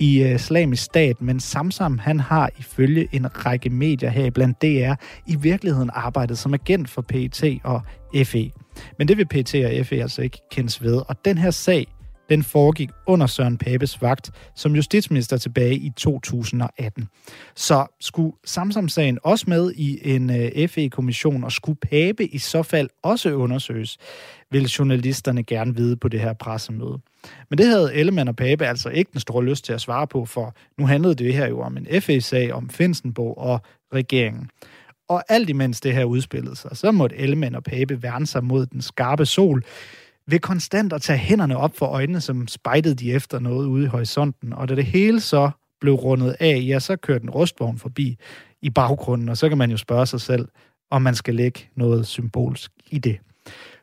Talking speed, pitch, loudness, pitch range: 185 wpm, 135 Hz, -21 LUFS, 125-150 Hz